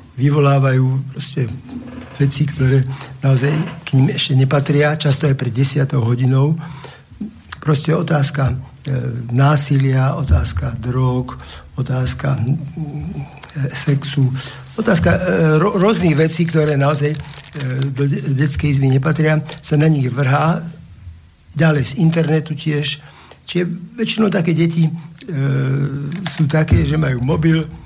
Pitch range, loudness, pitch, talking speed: 135-155 Hz, -17 LUFS, 145 Hz, 115 wpm